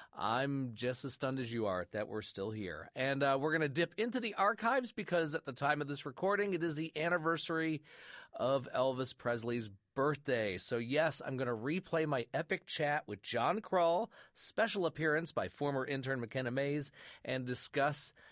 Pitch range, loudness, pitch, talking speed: 130-165 Hz, -36 LUFS, 145 Hz, 185 wpm